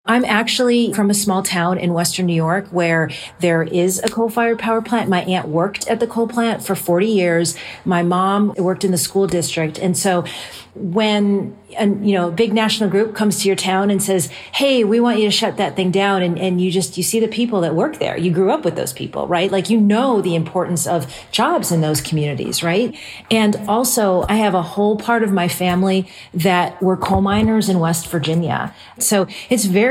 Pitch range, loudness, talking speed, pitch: 175-215 Hz, -17 LUFS, 215 wpm, 190 Hz